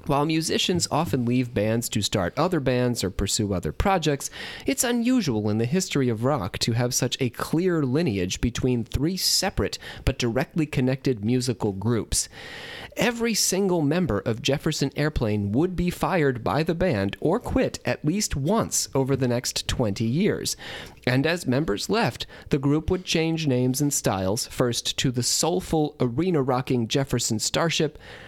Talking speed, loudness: 160 wpm, -24 LUFS